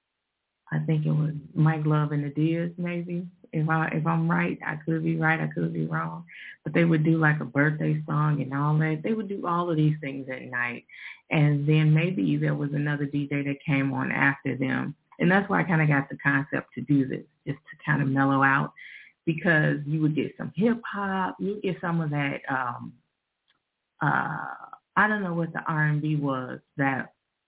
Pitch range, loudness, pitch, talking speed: 140-165 Hz, -26 LUFS, 150 Hz, 210 wpm